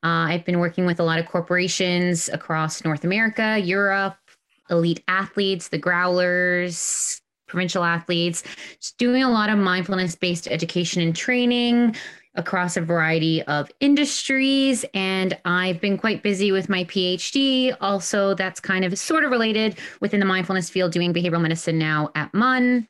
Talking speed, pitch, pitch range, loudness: 150 wpm, 185 Hz, 175-205 Hz, -21 LUFS